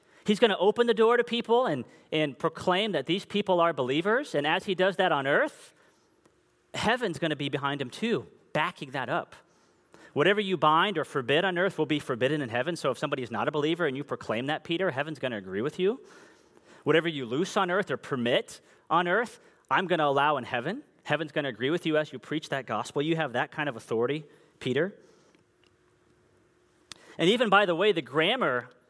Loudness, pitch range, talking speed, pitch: -28 LUFS, 145-195 Hz, 215 wpm, 165 Hz